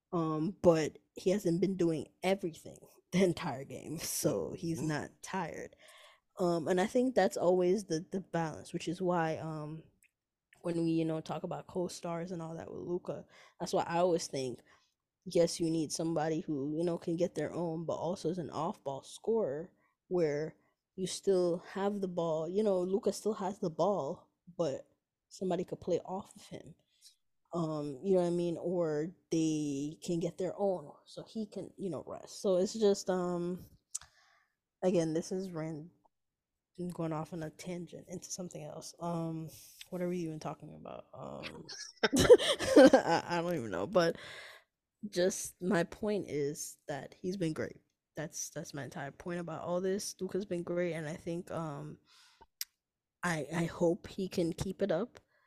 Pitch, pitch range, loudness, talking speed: 175 Hz, 160-185 Hz, -34 LUFS, 175 wpm